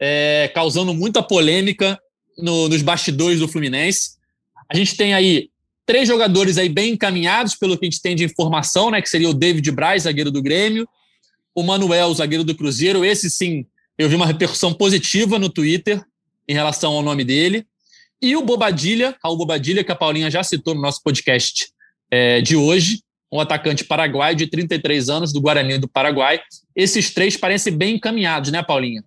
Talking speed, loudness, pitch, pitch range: 180 wpm, -17 LUFS, 170 Hz, 155-195 Hz